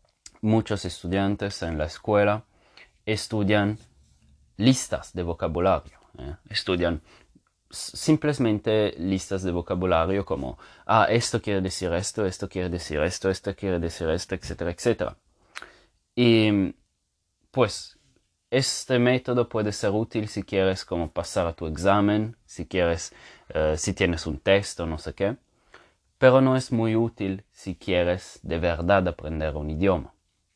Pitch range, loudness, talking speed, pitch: 85-110 Hz, -25 LUFS, 135 wpm, 95 Hz